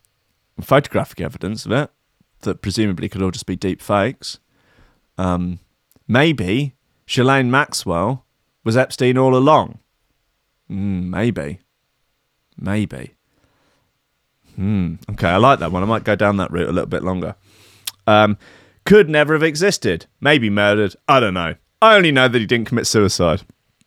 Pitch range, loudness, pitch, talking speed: 95-130 Hz, -17 LUFS, 105 Hz, 145 wpm